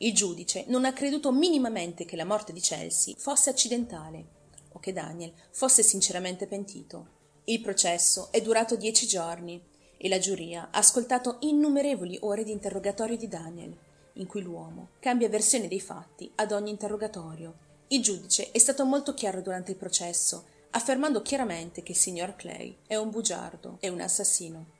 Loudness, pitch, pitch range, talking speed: -26 LUFS, 200 Hz, 175-235 Hz, 160 wpm